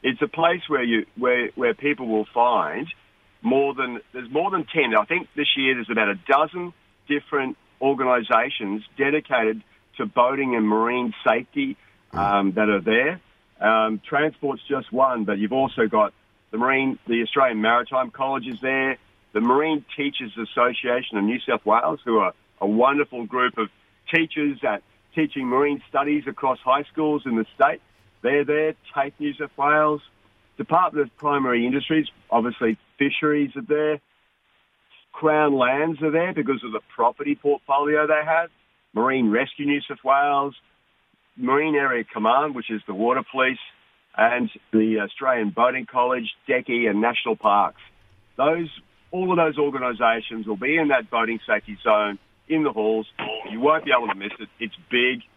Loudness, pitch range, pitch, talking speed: -22 LUFS, 115-145 Hz, 130 Hz, 160 wpm